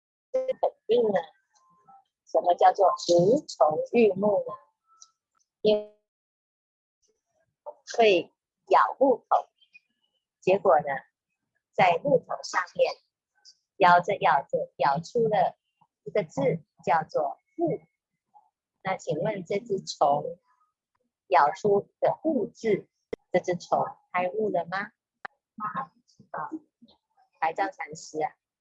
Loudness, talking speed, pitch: -26 LUFS, 135 characters per minute, 235 Hz